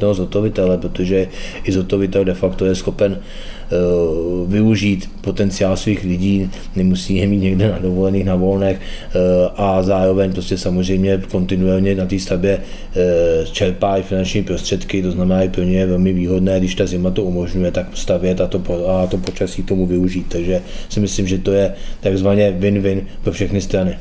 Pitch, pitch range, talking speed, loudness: 95 Hz, 90-100 Hz, 165 wpm, -17 LUFS